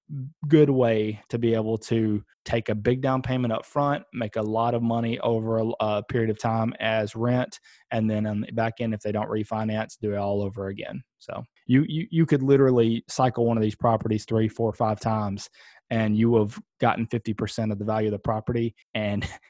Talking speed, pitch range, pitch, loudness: 205 wpm, 110-120 Hz, 115 Hz, -25 LUFS